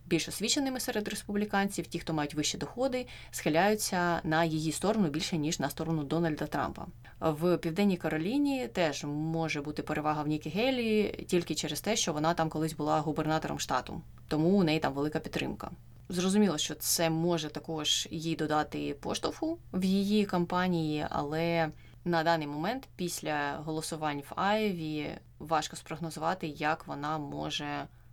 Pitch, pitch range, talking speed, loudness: 160 Hz, 155-180 Hz, 145 wpm, -31 LUFS